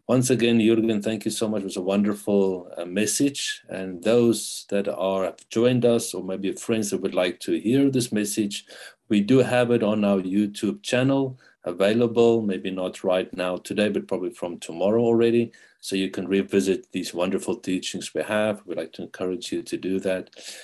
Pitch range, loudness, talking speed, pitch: 95-115 Hz, -24 LUFS, 190 wpm, 105 Hz